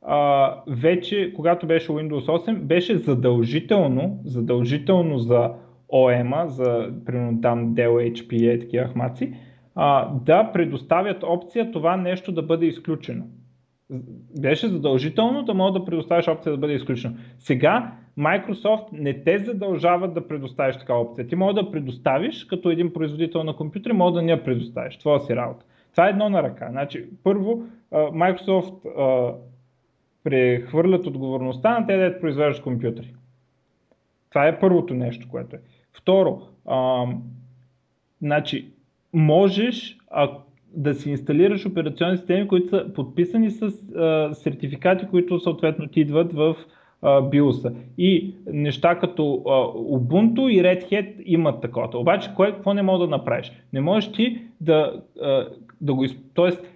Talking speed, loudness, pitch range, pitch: 140 wpm, -22 LUFS, 130-180 Hz, 155 Hz